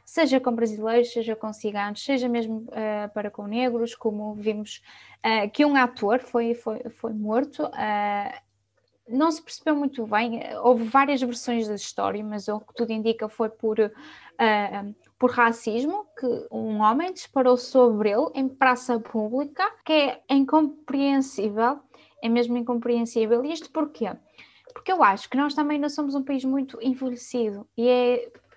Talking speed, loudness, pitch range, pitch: 160 wpm, -25 LUFS, 220-275 Hz, 240 Hz